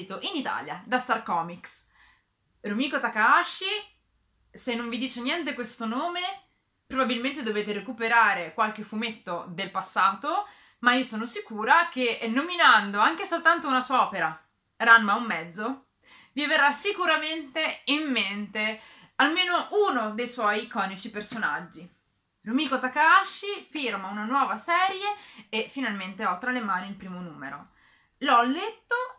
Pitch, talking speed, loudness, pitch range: 245 Hz, 130 wpm, -25 LUFS, 210-300 Hz